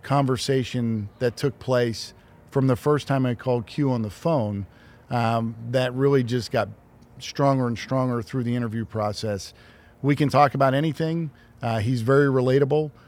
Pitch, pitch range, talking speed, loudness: 125 Hz, 115-135 Hz, 160 wpm, -24 LUFS